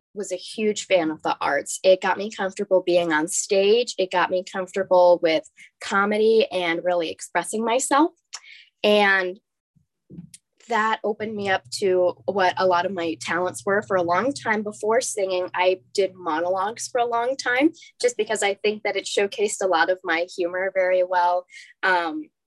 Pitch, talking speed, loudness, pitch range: 190 Hz, 175 wpm, -22 LUFS, 180-215 Hz